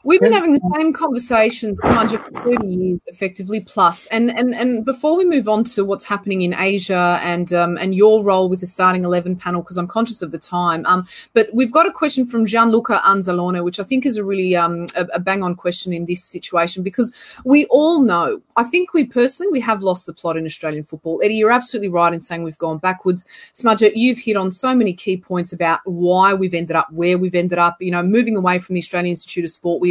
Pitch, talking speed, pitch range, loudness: 190 Hz, 235 wpm, 175-235 Hz, -17 LUFS